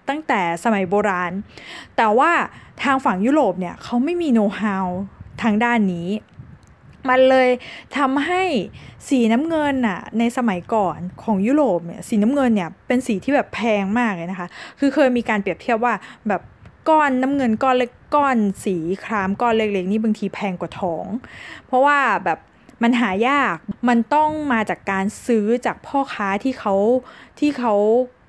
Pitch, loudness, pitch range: 230 Hz, -20 LUFS, 200-260 Hz